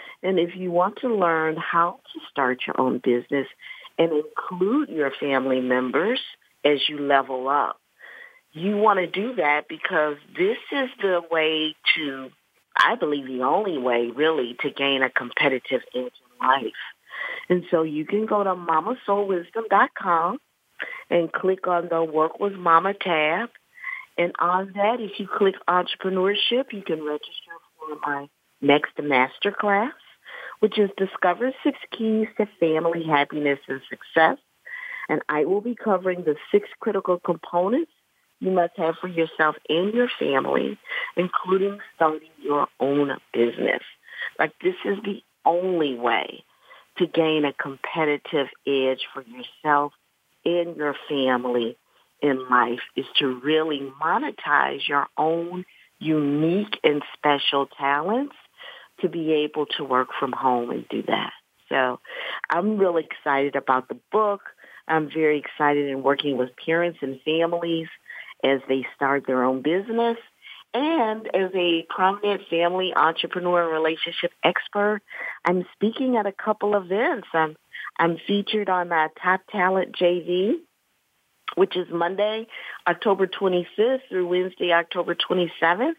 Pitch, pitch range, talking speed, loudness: 170 Hz, 145-200 Hz, 135 wpm, -23 LUFS